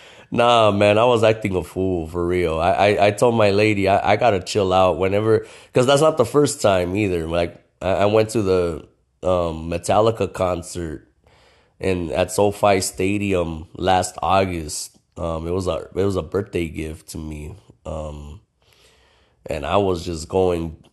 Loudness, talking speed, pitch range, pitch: -19 LUFS, 170 wpm, 85-105 Hz, 95 Hz